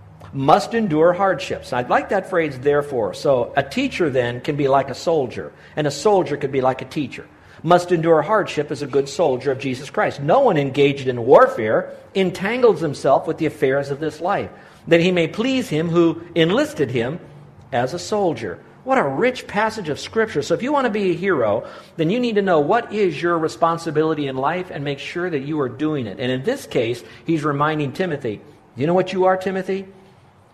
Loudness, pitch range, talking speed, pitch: -20 LUFS, 140-190 Hz, 205 wpm, 160 Hz